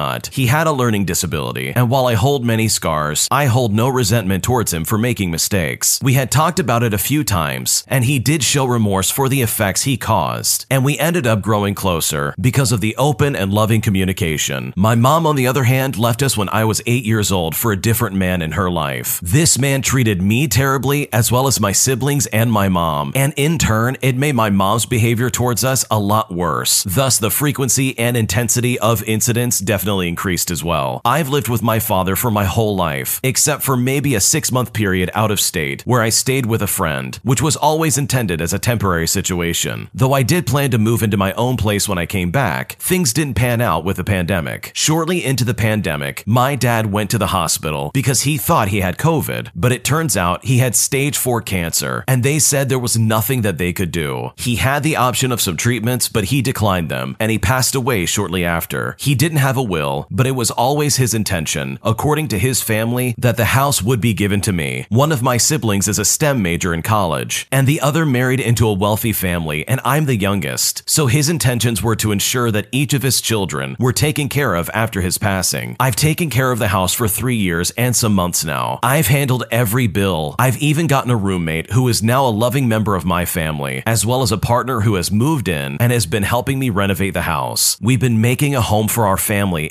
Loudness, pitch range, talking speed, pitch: -16 LUFS, 95-130 Hz, 225 wpm, 115 Hz